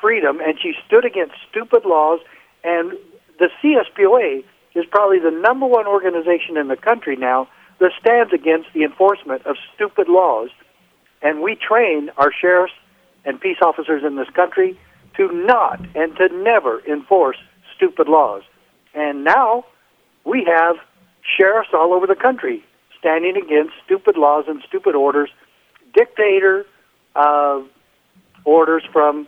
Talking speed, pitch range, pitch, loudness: 135 wpm, 155-240 Hz, 180 Hz, -16 LUFS